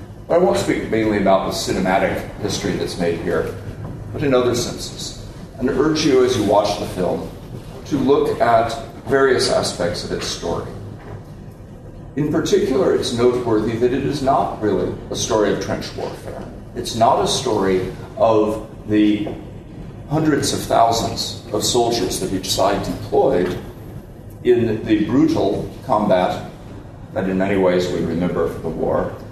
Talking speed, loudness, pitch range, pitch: 150 wpm, -19 LUFS, 100-125 Hz, 115 Hz